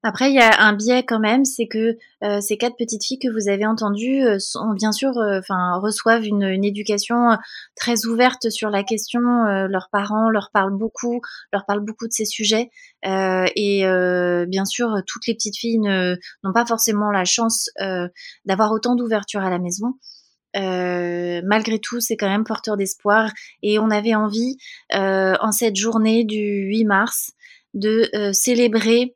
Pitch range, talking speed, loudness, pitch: 200-230 Hz, 185 wpm, -19 LUFS, 215 Hz